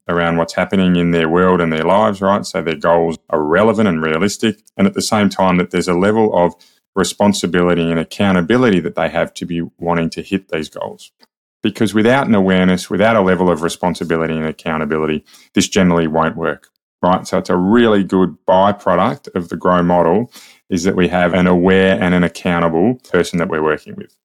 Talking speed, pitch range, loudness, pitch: 200 wpm, 85-95 Hz, -15 LUFS, 90 Hz